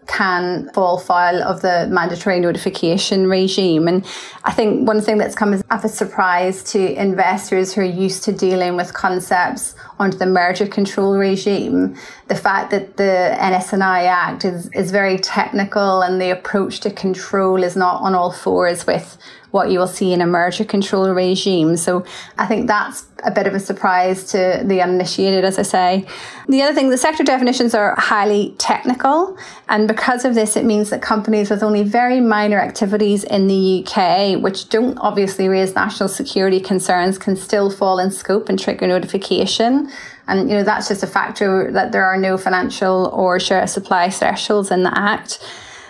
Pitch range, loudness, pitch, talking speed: 185-210 Hz, -16 LUFS, 195 Hz, 180 wpm